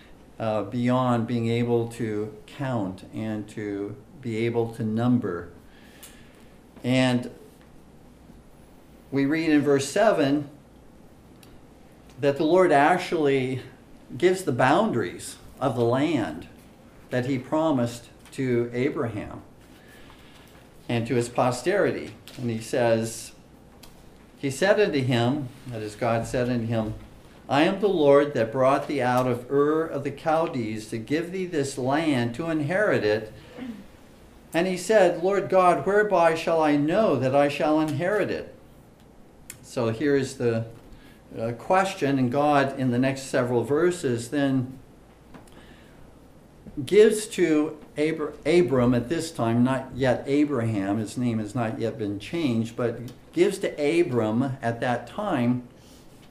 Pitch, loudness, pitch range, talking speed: 130 Hz, -24 LUFS, 115-150 Hz, 130 wpm